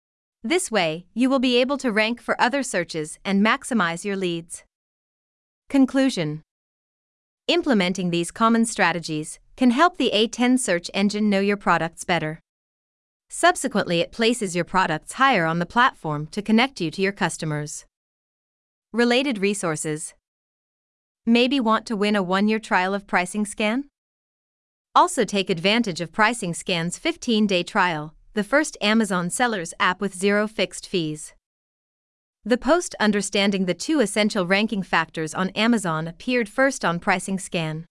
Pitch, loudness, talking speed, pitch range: 200 Hz, -22 LUFS, 140 wpm, 175-235 Hz